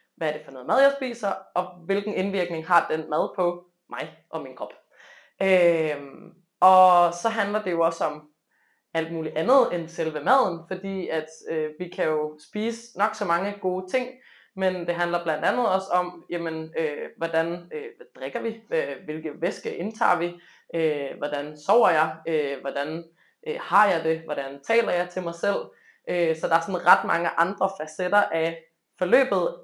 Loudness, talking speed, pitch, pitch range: -25 LUFS, 180 wpm, 175 Hz, 160-195 Hz